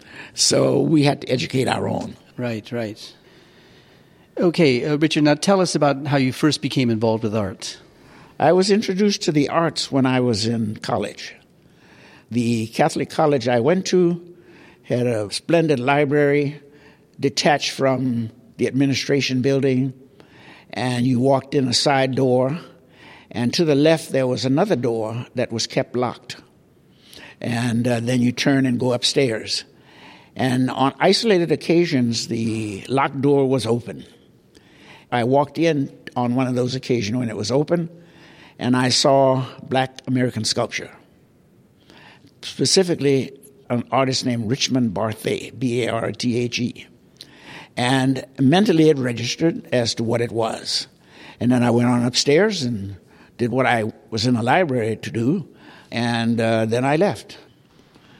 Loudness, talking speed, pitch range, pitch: -20 LUFS, 150 wpm, 120-145 Hz, 130 Hz